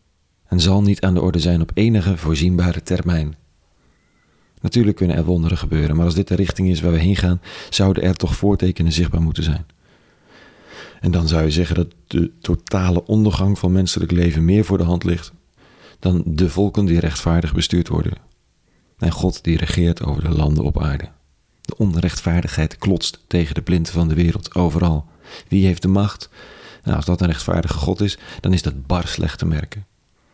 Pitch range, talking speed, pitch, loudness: 80-90 Hz, 185 wpm, 85 Hz, -19 LUFS